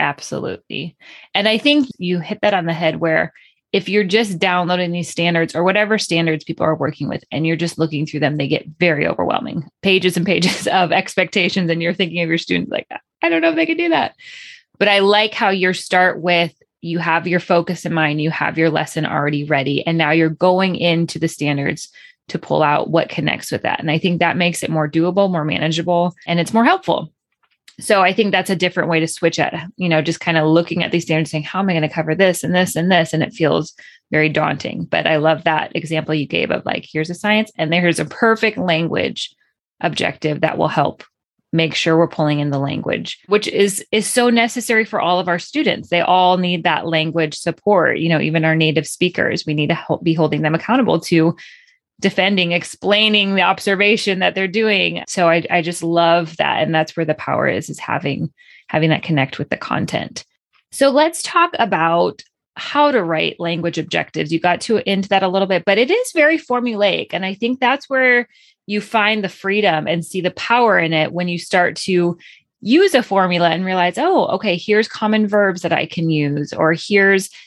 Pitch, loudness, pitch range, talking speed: 175 Hz, -17 LUFS, 160-205 Hz, 220 wpm